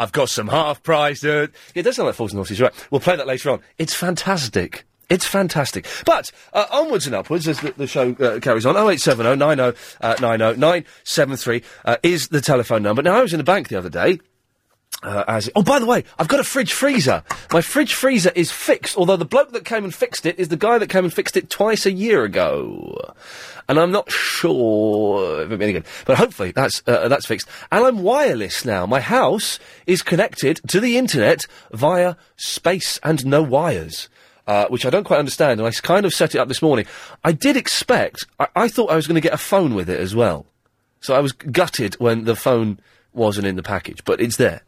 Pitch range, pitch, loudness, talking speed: 120-195 Hz, 160 Hz, -18 LUFS, 230 wpm